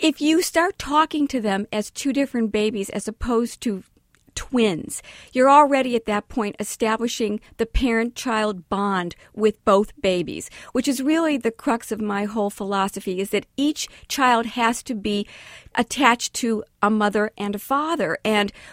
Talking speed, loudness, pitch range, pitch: 165 wpm, -22 LUFS, 205-255 Hz, 225 Hz